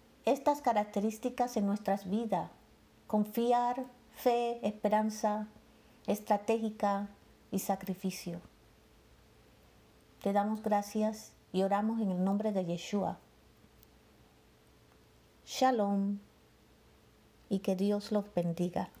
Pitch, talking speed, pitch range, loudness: 210 Hz, 85 wpm, 195-220 Hz, -33 LUFS